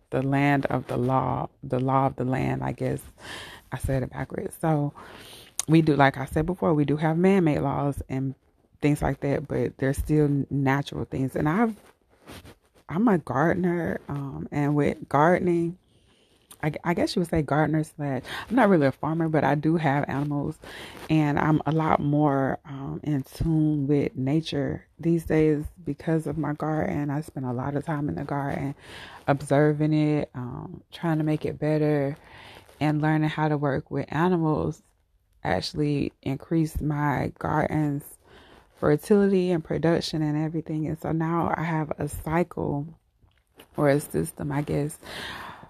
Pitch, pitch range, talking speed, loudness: 150 Hz, 140-160 Hz, 165 wpm, -26 LUFS